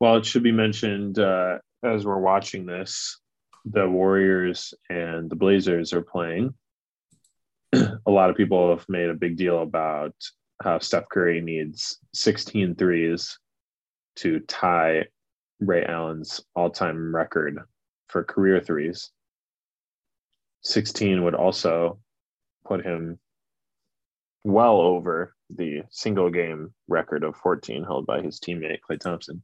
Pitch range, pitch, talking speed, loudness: 85-100 Hz, 90 Hz, 125 wpm, -24 LUFS